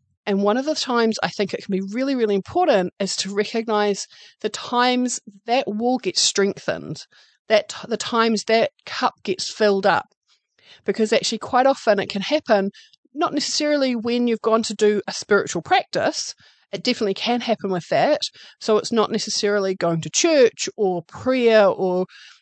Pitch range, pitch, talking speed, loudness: 200-250 Hz, 220 Hz, 170 wpm, -21 LUFS